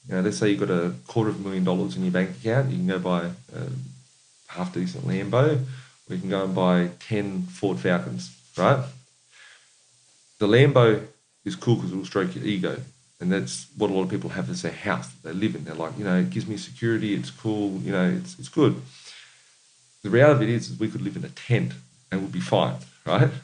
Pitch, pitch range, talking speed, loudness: 90 Hz, 65-105 Hz, 235 wpm, -25 LUFS